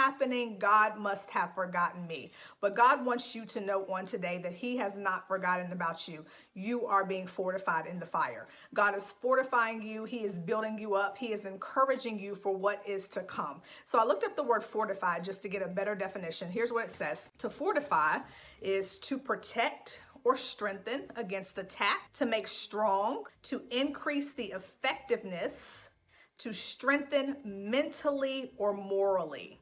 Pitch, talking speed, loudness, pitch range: 205 Hz, 170 wpm, -33 LUFS, 195-245 Hz